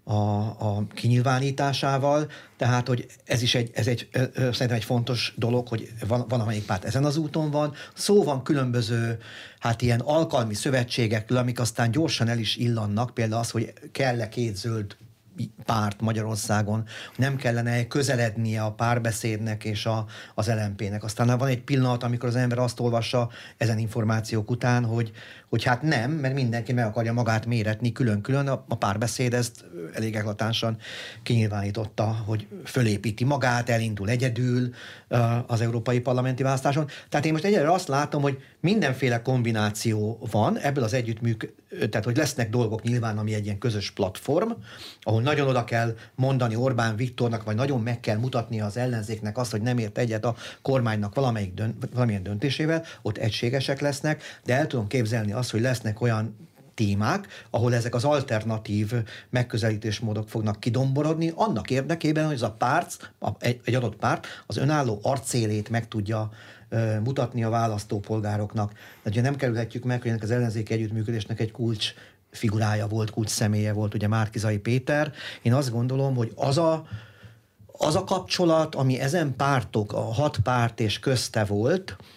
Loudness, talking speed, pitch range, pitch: -26 LUFS, 155 wpm, 110-130 Hz, 120 Hz